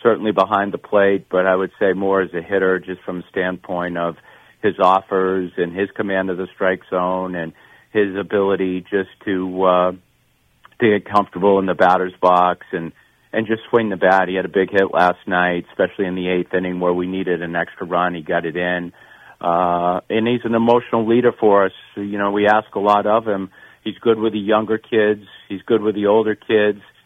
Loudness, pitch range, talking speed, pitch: -18 LUFS, 90-105 Hz, 210 wpm, 95 Hz